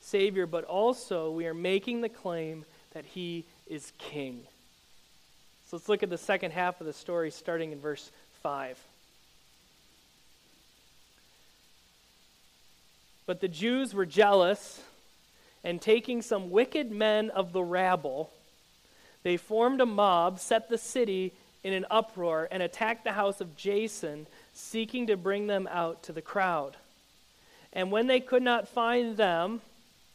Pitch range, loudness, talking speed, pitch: 165-220 Hz, -30 LUFS, 140 wpm, 190 Hz